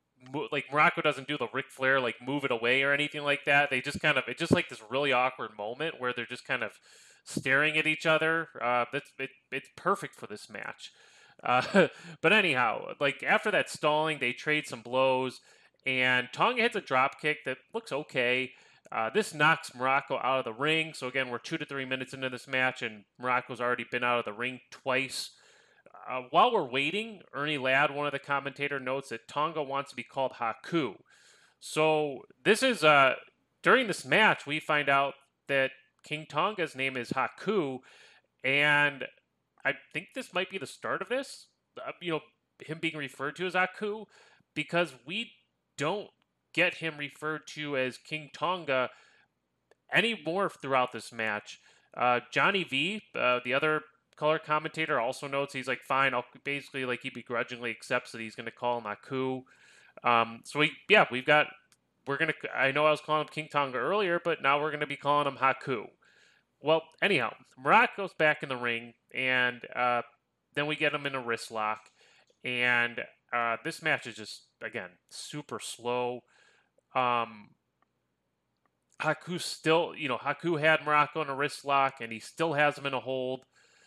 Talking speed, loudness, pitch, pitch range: 180 wpm, -29 LUFS, 140 Hz, 125-155 Hz